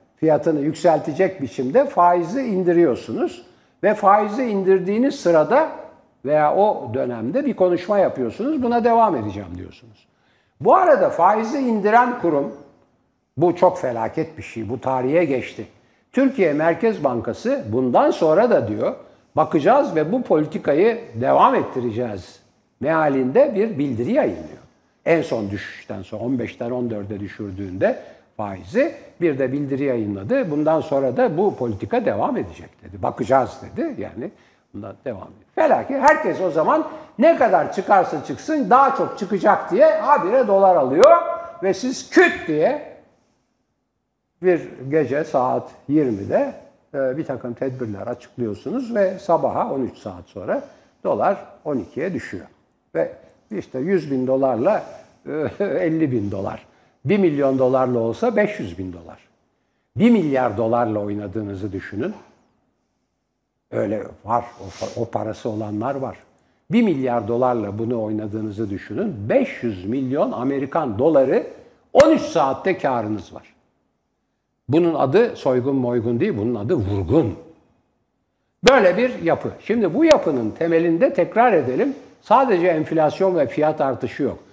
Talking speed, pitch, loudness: 125 wpm, 155 Hz, -20 LUFS